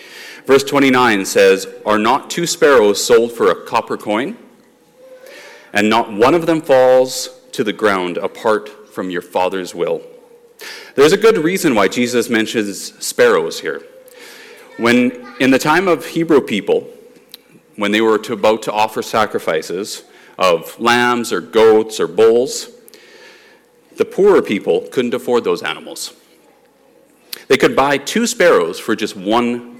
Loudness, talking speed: -15 LUFS, 145 wpm